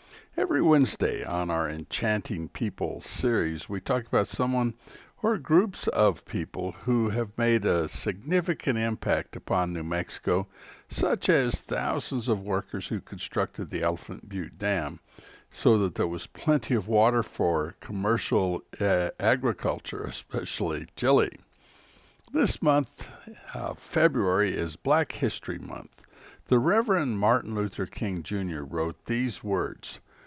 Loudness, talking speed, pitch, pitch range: -28 LUFS, 130 wpm, 105 Hz, 90-125 Hz